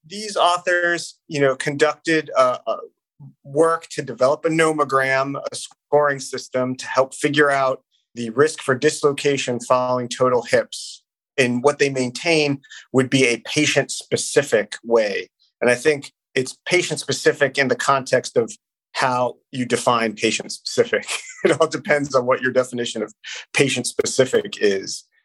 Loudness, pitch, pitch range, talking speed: -20 LUFS, 145 Hz, 130-165 Hz, 145 wpm